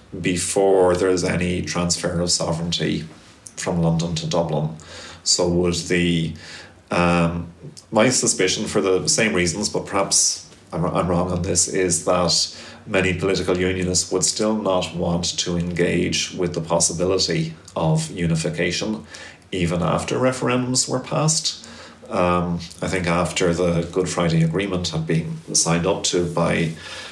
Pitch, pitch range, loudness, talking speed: 85 Hz, 85-90 Hz, -20 LUFS, 140 wpm